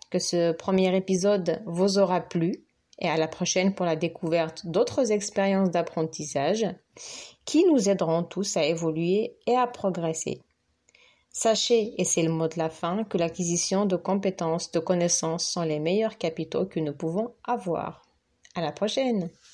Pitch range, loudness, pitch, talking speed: 165-205 Hz, -26 LUFS, 180 Hz, 155 wpm